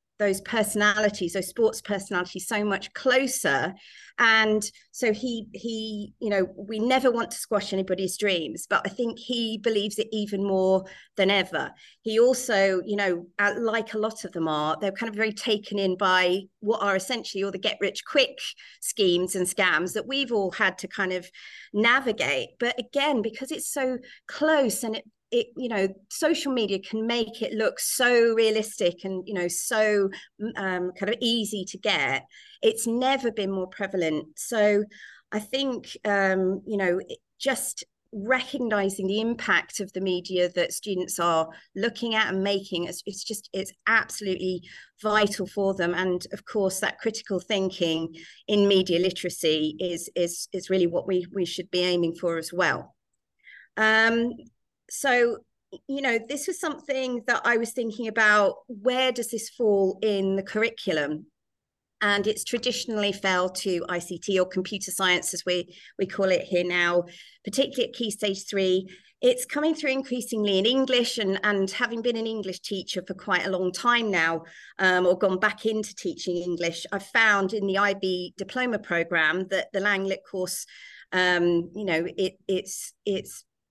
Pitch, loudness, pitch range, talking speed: 205 Hz, -25 LUFS, 185-230 Hz, 170 wpm